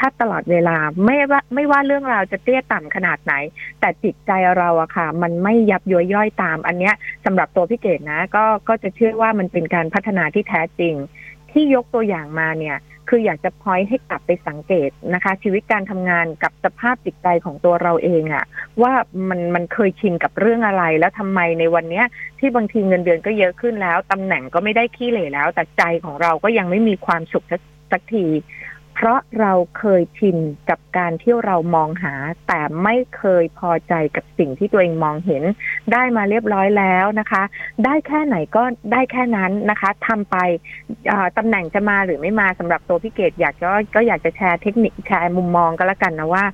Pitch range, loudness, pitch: 170-220 Hz, -18 LUFS, 185 Hz